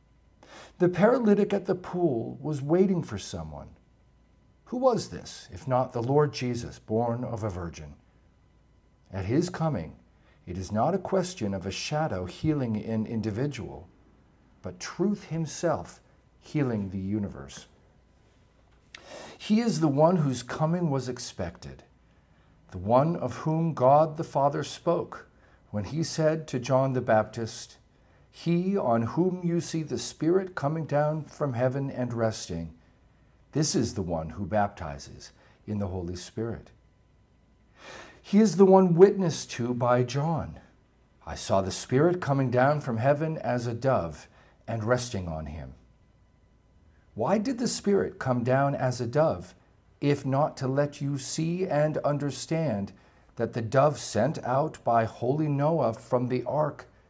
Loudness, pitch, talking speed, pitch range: -27 LUFS, 130 Hz, 145 wpm, 110-160 Hz